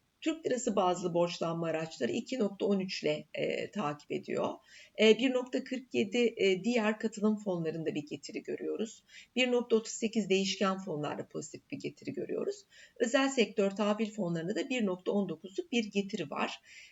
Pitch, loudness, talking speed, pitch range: 215 Hz, -33 LUFS, 125 wpm, 190-245 Hz